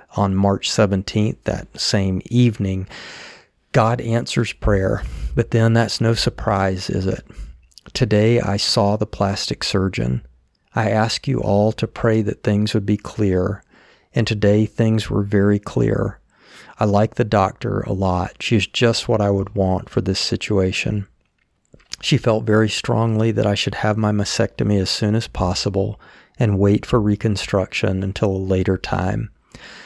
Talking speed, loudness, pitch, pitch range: 155 wpm, -19 LUFS, 105 Hz, 95-115 Hz